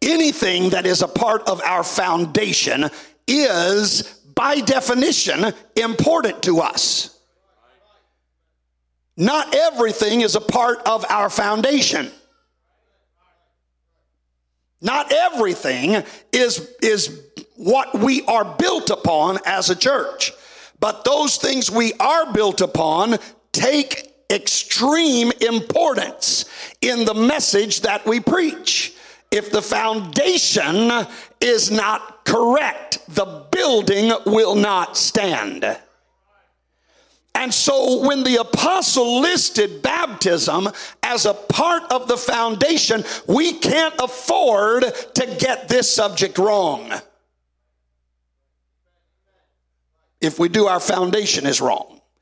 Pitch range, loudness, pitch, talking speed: 190-270 Hz, -18 LUFS, 225 Hz, 100 wpm